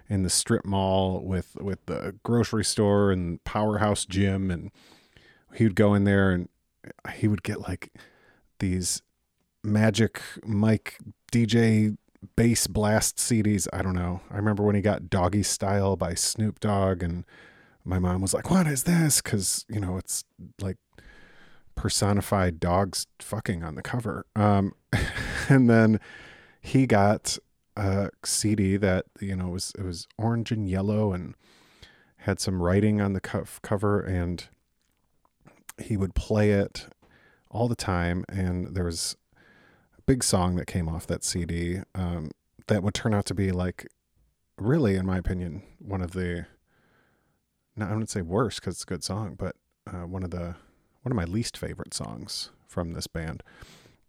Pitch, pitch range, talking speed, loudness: 100 Hz, 90-105 Hz, 160 wpm, -26 LUFS